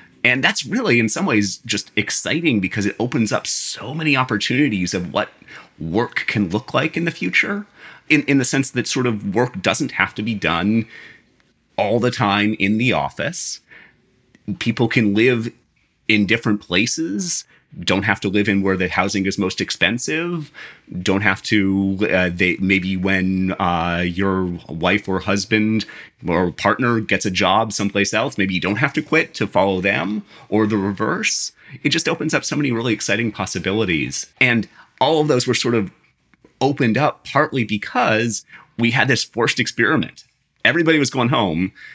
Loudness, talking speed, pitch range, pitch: -19 LUFS, 170 wpm, 95-130 Hz, 110 Hz